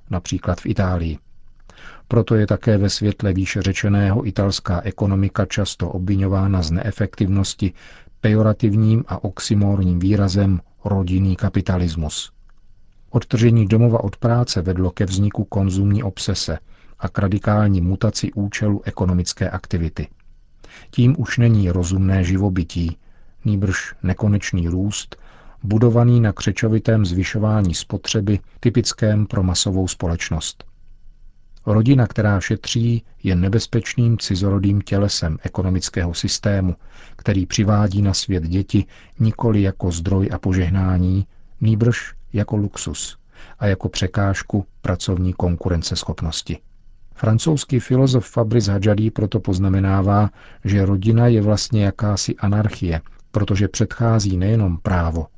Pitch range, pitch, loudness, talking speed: 95-110 Hz, 100 Hz, -19 LUFS, 105 wpm